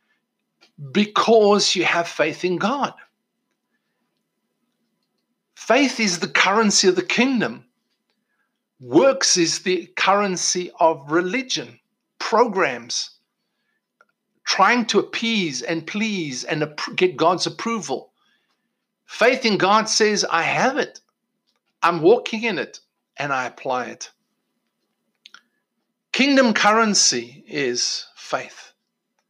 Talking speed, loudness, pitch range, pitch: 100 wpm, -19 LUFS, 175-230 Hz, 205 Hz